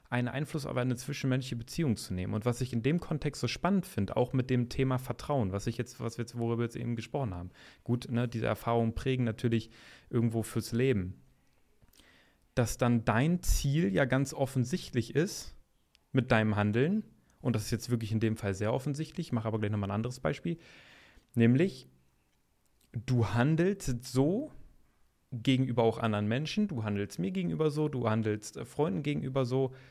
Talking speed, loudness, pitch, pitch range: 180 wpm, -32 LUFS, 120 Hz, 115-135 Hz